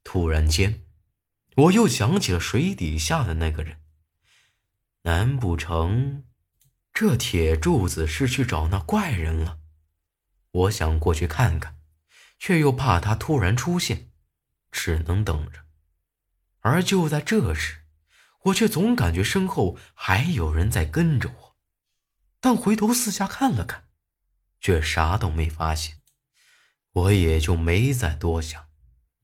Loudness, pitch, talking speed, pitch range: -23 LUFS, 90 Hz, 180 characters per minute, 80-130 Hz